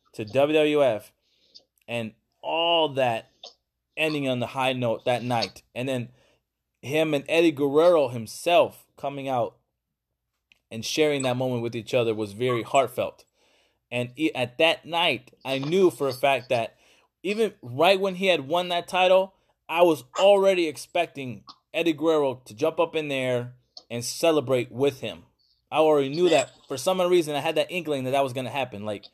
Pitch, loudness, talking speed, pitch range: 140 Hz, -24 LUFS, 170 wpm, 120-160 Hz